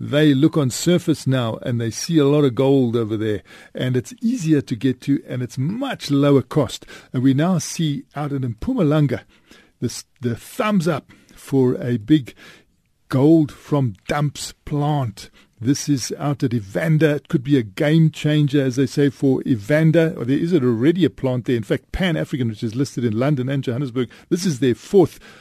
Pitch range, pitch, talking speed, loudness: 125-150 Hz, 140 Hz, 190 wpm, -20 LUFS